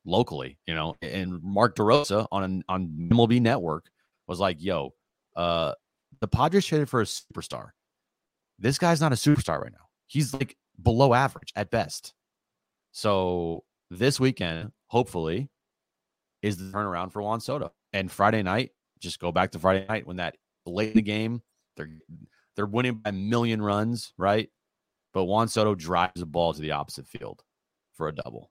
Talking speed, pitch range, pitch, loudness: 165 wpm, 90-120 Hz, 105 Hz, -27 LUFS